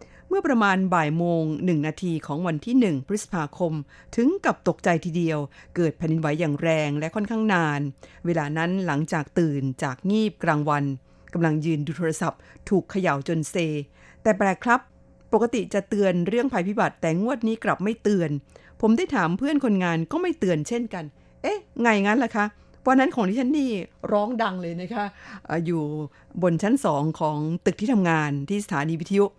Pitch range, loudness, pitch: 160-215 Hz, -24 LUFS, 180 Hz